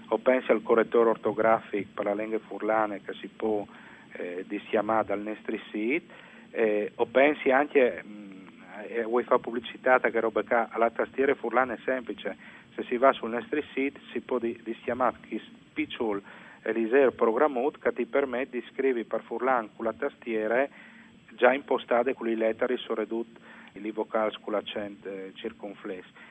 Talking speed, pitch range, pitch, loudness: 155 wpm, 110-125 Hz, 115 Hz, -28 LUFS